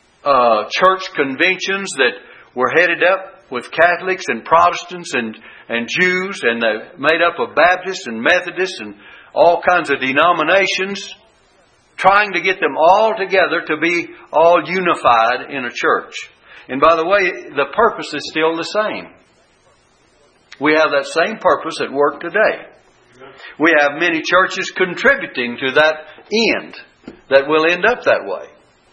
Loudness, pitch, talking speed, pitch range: -15 LUFS, 175 Hz, 145 wpm, 155-190 Hz